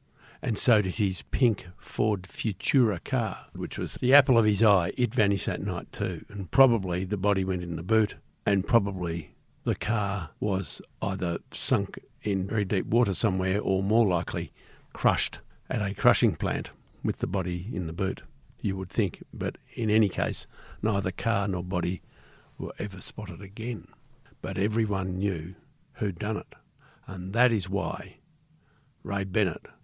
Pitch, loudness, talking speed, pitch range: 100 Hz, -28 LUFS, 165 wpm, 95-115 Hz